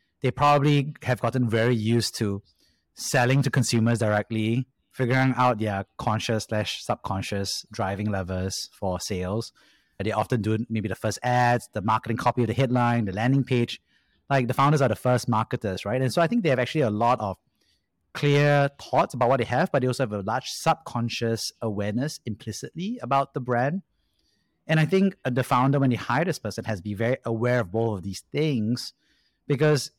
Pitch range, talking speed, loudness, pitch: 110-135 Hz, 190 wpm, -25 LUFS, 120 Hz